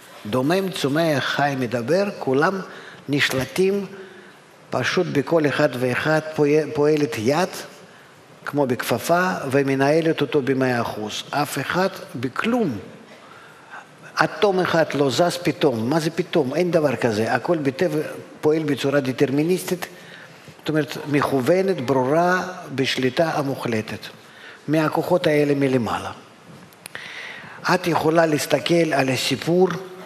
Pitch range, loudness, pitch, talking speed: 135-175 Hz, -21 LUFS, 150 Hz, 100 wpm